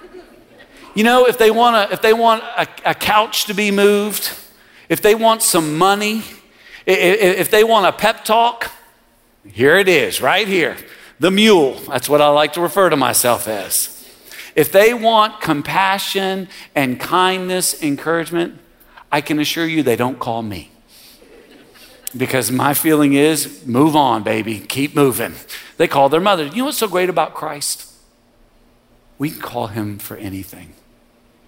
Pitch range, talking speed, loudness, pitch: 130-205 Hz, 160 wpm, -15 LUFS, 165 Hz